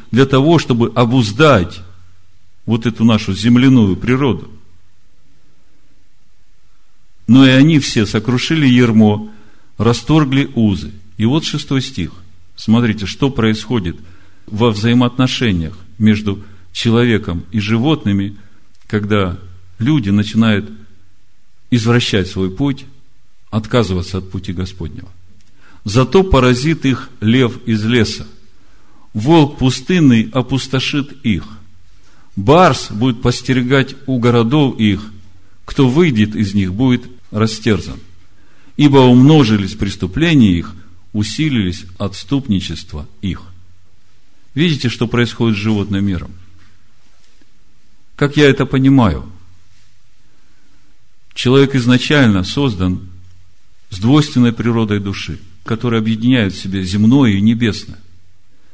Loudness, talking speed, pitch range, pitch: -14 LUFS, 95 wpm, 95-125 Hz, 110 Hz